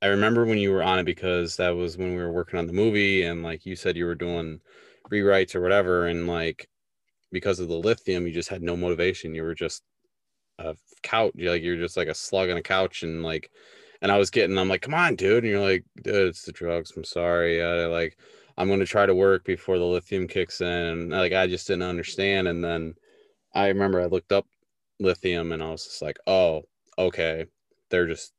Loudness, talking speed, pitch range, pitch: -25 LUFS, 230 wpm, 85-95 Hz, 90 Hz